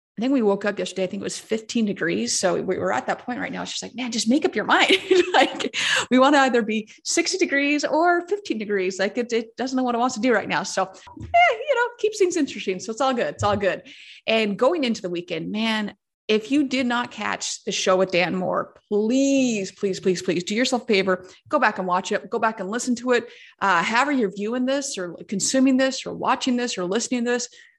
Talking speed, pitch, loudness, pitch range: 250 wpm, 240 Hz, -22 LUFS, 205-275 Hz